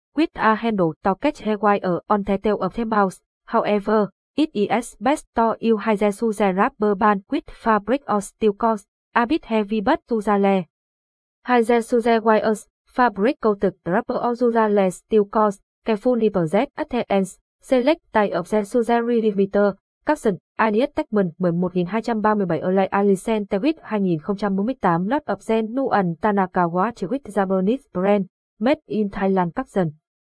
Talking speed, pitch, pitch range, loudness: 150 wpm, 215 Hz, 195-235 Hz, -21 LUFS